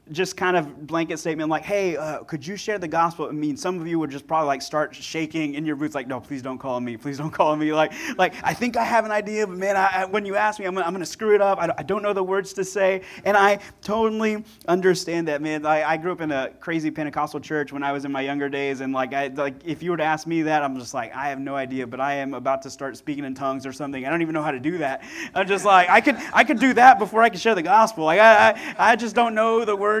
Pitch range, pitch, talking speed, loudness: 145-200 Hz, 165 Hz, 310 wpm, -22 LUFS